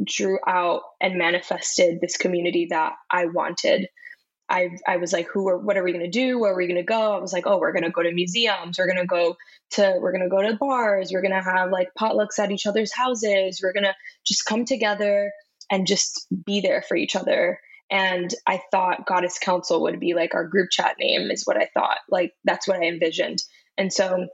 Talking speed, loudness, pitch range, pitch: 215 wpm, -23 LUFS, 180-205 Hz, 190 Hz